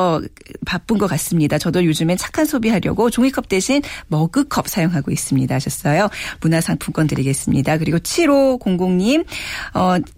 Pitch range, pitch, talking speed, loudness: 155-235 Hz, 180 Hz, 325 characters per minute, -18 LUFS